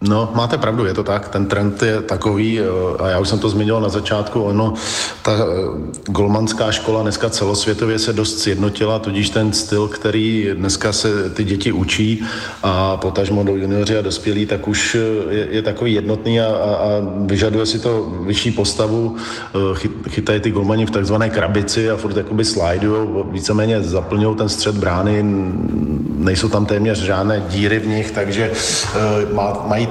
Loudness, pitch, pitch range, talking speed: -17 LUFS, 105 Hz, 100-110 Hz, 165 wpm